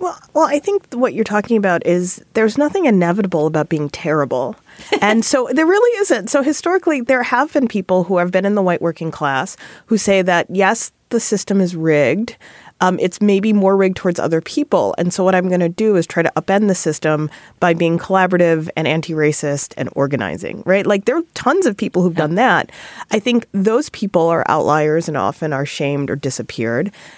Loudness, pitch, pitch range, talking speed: -16 LUFS, 185 Hz, 160-225 Hz, 205 wpm